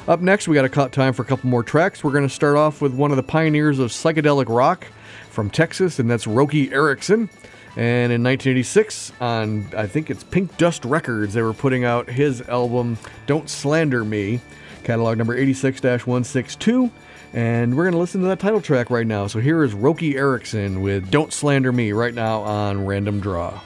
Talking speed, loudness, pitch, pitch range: 200 wpm, -20 LUFS, 130 Hz, 115-150 Hz